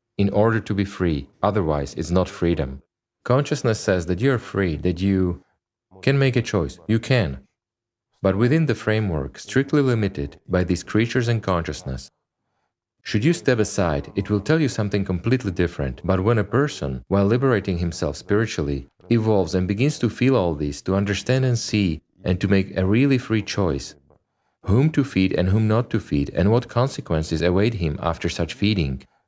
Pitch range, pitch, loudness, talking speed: 85-120 Hz, 100 Hz, -22 LUFS, 180 wpm